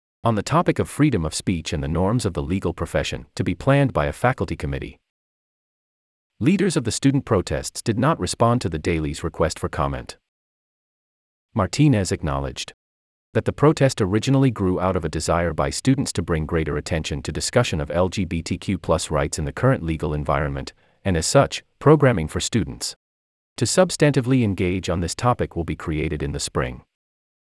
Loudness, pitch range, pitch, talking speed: -22 LUFS, 75-110 Hz, 85 Hz, 175 wpm